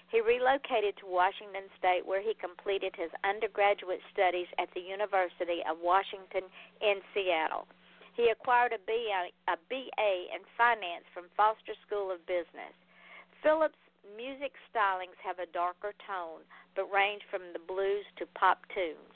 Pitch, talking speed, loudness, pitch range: 195 Hz, 145 wpm, -32 LUFS, 180-215 Hz